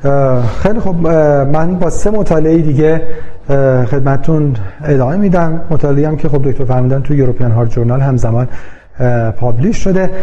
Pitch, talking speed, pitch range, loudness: 140 Hz, 130 wpm, 125-160 Hz, -13 LUFS